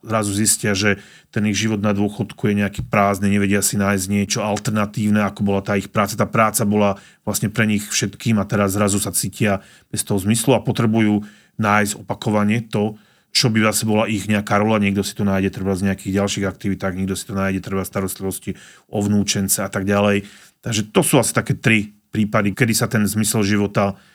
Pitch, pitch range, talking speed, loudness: 105 Hz, 100-110 Hz, 200 wpm, -19 LUFS